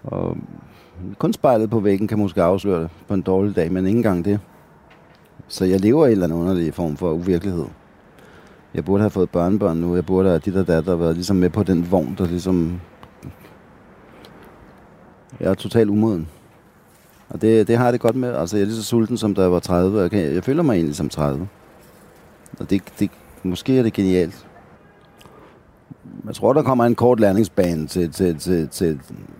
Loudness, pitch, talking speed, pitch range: -19 LUFS, 95 Hz, 200 wpm, 85-105 Hz